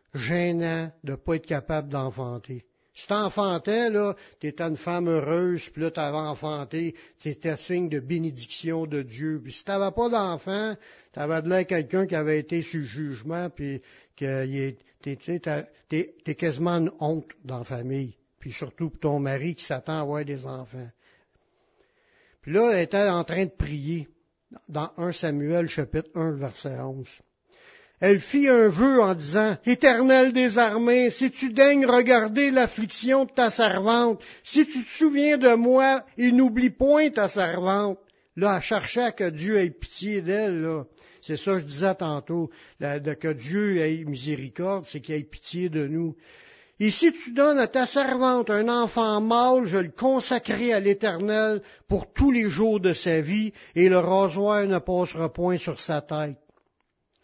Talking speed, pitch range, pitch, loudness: 170 wpm, 155-220 Hz, 175 Hz, -24 LUFS